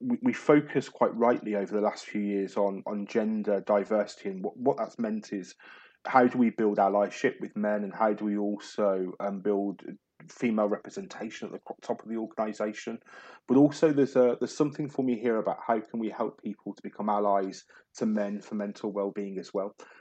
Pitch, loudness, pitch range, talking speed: 105 Hz, -29 LUFS, 100-125 Hz, 200 wpm